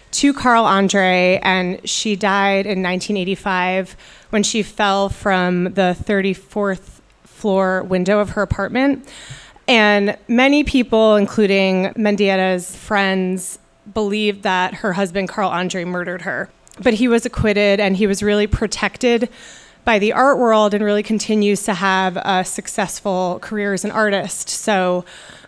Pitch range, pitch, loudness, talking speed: 190-215 Hz, 200 Hz, -17 LUFS, 135 wpm